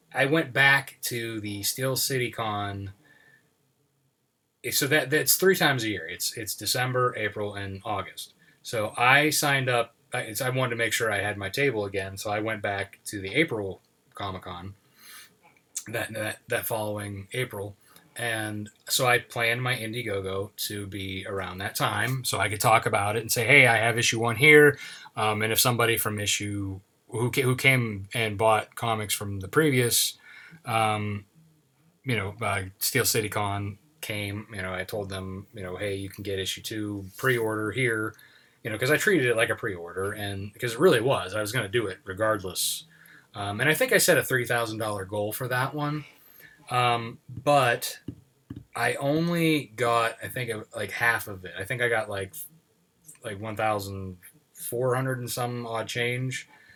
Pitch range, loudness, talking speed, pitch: 105-130 Hz, -26 LUFS, 185 wpm, 115 Hz